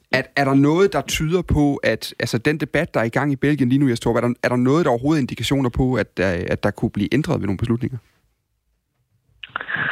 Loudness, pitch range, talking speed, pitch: -20 LUFS, 115-140 Hz, 240 wpm, 125 Hz